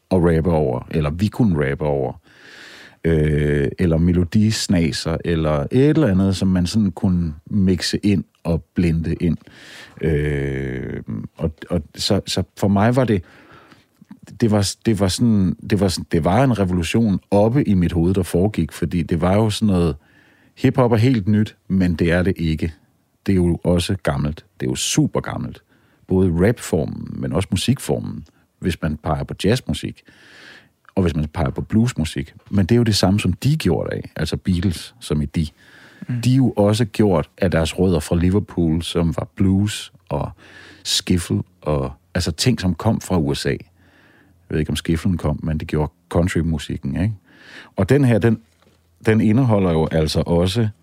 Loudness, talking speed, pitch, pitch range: -19 LUFS, 175 wpm, 90 Hz, 80-105 Hz